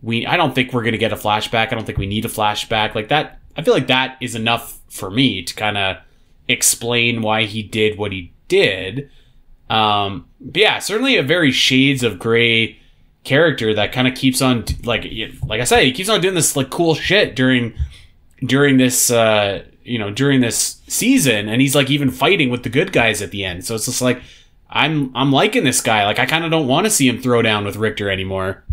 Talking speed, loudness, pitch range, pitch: 225 wpm, -16 LUFS, 105-130 Hz, 115 Hz